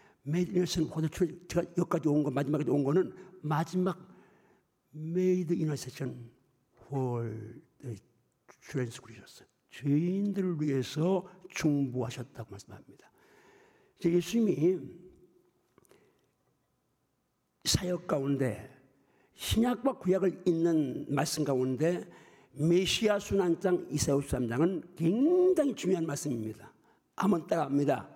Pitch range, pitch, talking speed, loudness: 135-185 Hz, 160 Hz, 220 characters per minute, -31 LUFS